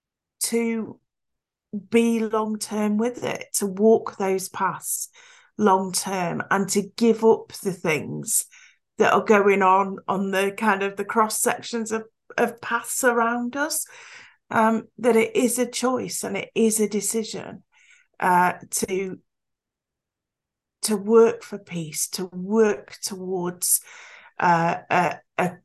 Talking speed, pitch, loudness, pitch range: 135 wpm, 215 Hz, -23 LUFS, 190-230 Hz